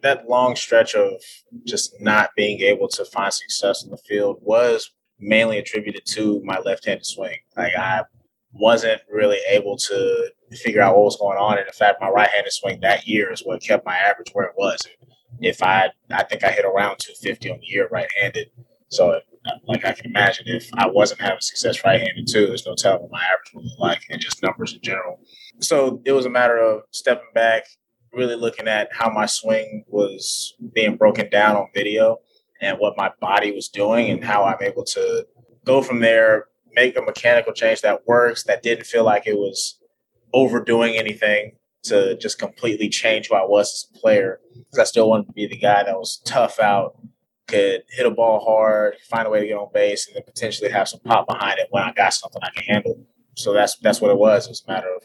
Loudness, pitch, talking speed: -19 LUFS, 130 Hz, 215 wpm